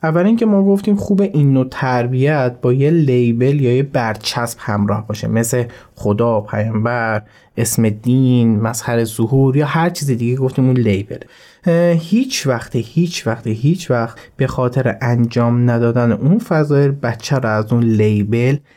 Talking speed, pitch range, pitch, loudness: 150 wpm, 115-140 Hz, 125 Hz, -16 LUFS